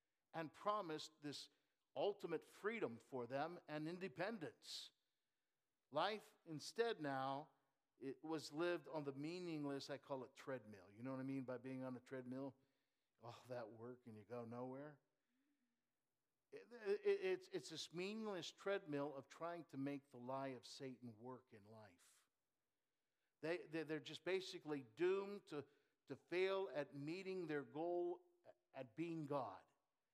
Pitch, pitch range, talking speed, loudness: 145 Hz, 130-175 Hz, 145 wpm, -49 LUFS